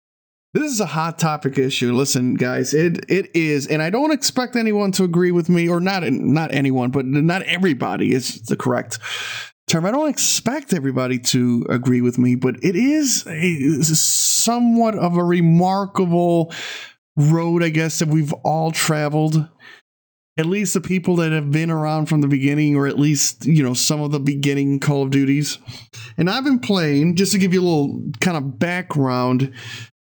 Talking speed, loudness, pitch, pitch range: 185 wpm, -18 LUFS, 155 Hz, 140-185 Hz